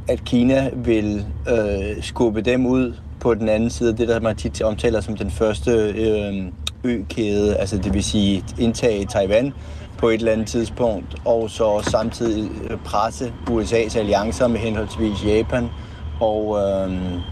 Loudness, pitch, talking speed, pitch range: -21 LUFS, 110 Hz, 150 wpm, 100-115 Hz